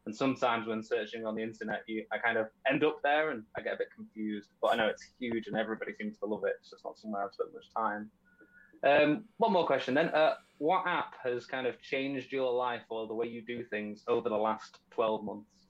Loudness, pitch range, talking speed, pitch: -33 LUFS, 110-155 Hz, 250 wpm, 120 Hz